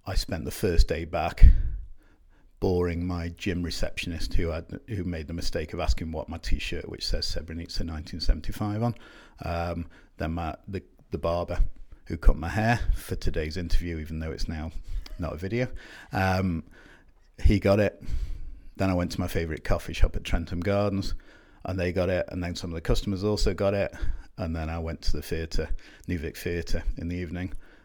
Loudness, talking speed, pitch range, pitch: -30 LUFS, 185 wpm, 80-95 Hz, 85 Hz